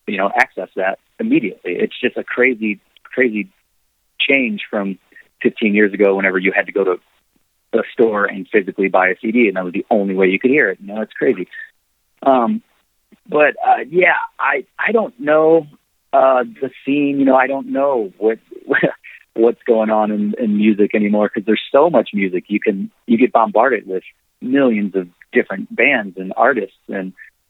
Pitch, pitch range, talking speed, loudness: 110 Hz, 100-140 Hz, 185 wpm, -16 LUFS